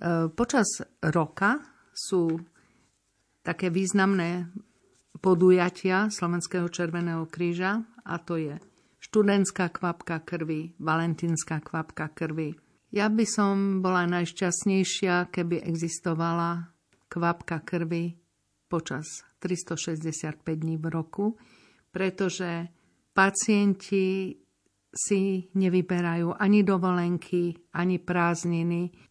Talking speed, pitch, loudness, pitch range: 80 wpm, 175 Hz, -27 LUFS, 165-190 Hz